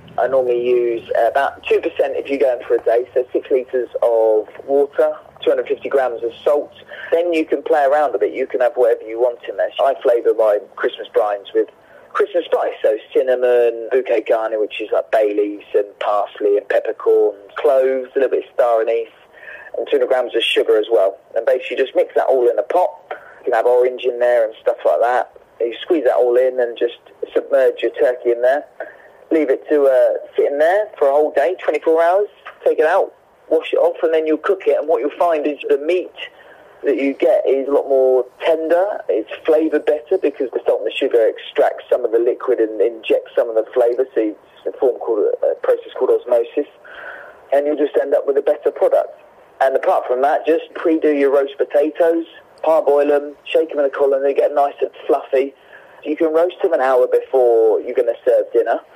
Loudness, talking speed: -17 LUFS, 215 wpm